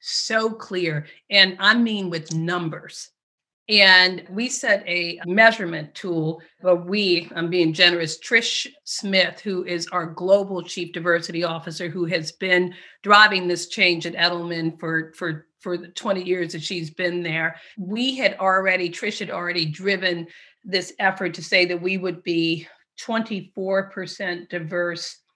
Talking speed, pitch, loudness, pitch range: 145 wpm, 180 Hz, -21 LUFS, 170-195 Hz